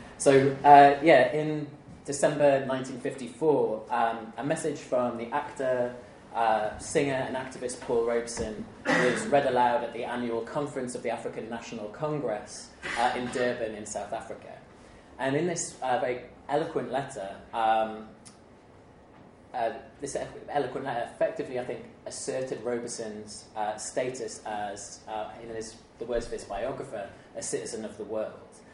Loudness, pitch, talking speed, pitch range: -28 LUFS, 120 Hz, 145 wpm, 110-140 Hz